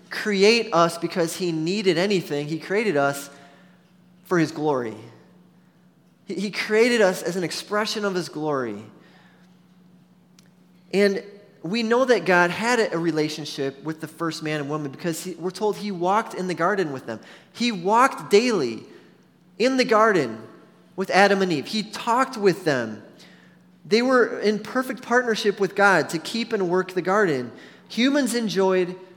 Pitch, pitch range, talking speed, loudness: 185 Hz, 170-205 Hz, 155 wpm, -22 LUFS